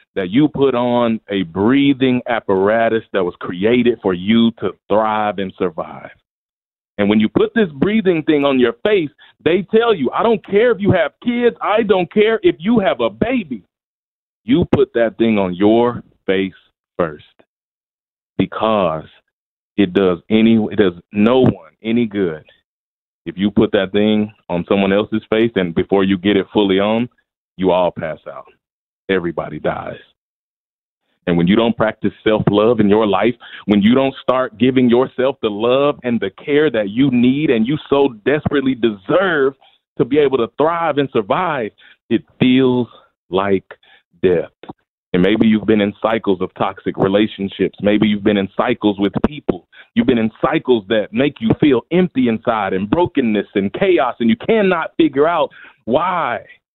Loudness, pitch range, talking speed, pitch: -16 LUFS, 105-145 Hz, 170 wpm, 115 Hz